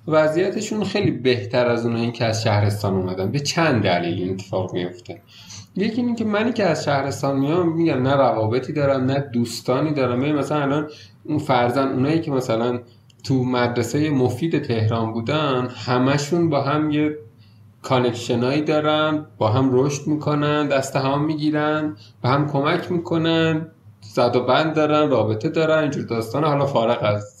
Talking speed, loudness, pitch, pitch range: 160 wpm, -21 LUFS, 135 Hz, 120-155 Hz